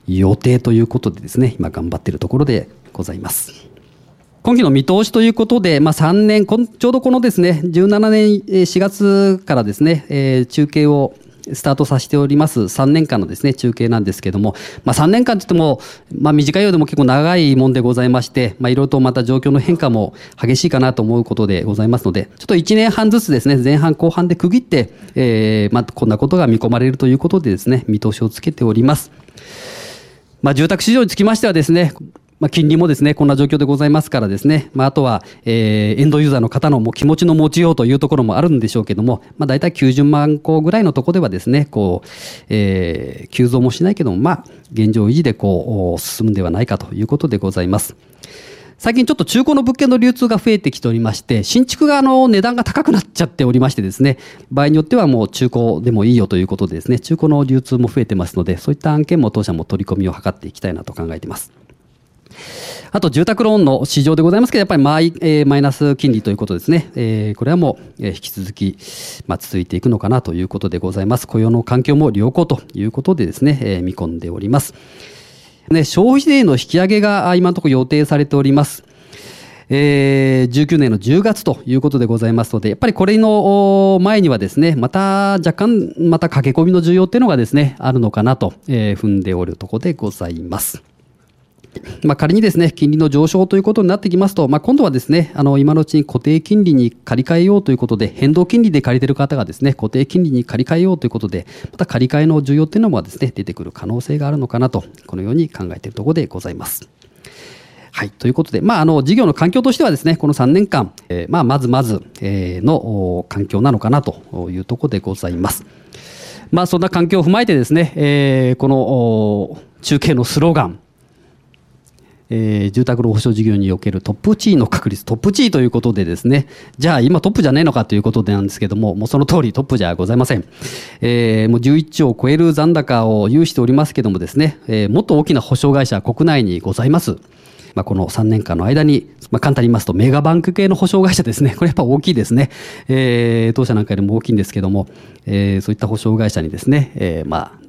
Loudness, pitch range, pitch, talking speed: -14 LUFS, 110-165 Hz, 135 Hz, 435 characters per minute